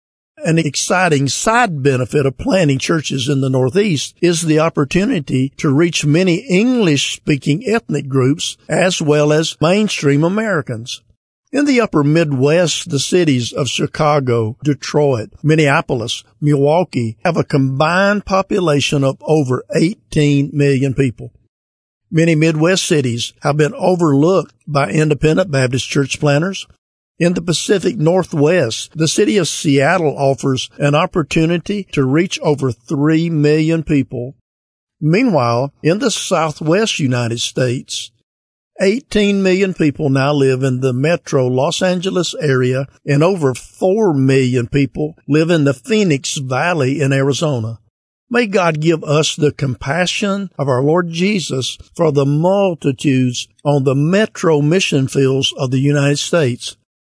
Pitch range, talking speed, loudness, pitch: 135-170 Hz, 130 wpm, -15 LUFS, 150 Hz